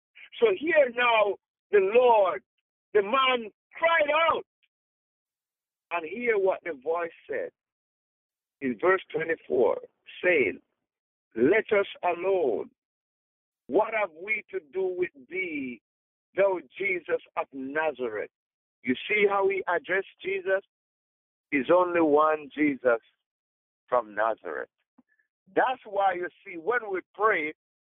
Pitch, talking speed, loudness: 220 Hz, 110 wpm, -27 LUFS